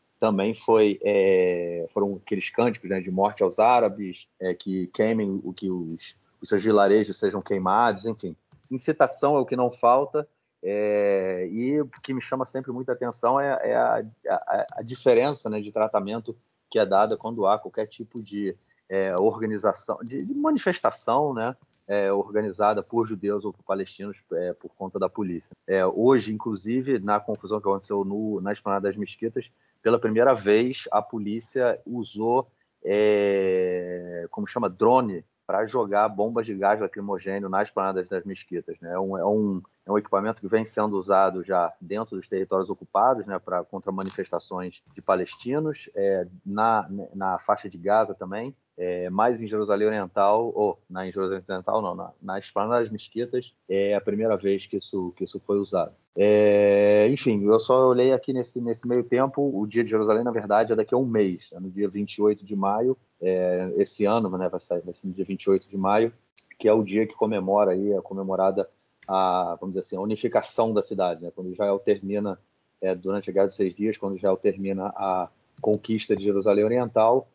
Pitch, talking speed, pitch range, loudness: 105 Hz, 185 wpm, 95-115 Hz, -25 LUFS